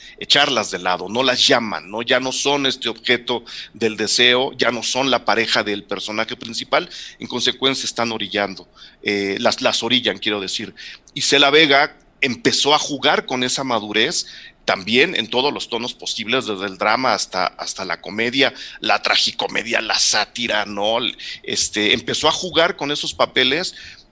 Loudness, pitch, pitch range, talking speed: -18 LUFS, 115 Hz, 105-130 Hz, 165 wpm